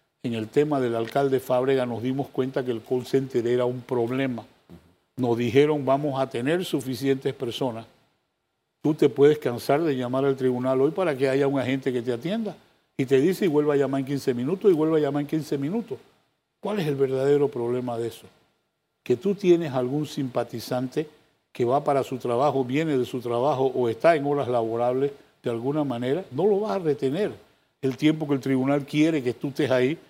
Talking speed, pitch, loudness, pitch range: 200 wpm, 135 Hz, -25 LUFS, 125-145 Hz